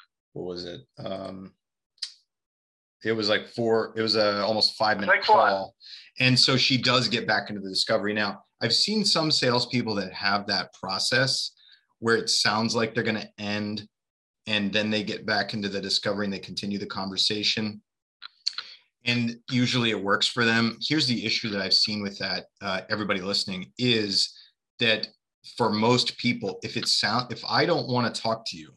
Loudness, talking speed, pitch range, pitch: -24 LUFS, 180 wpm, 100-120 Hz, 110 Hz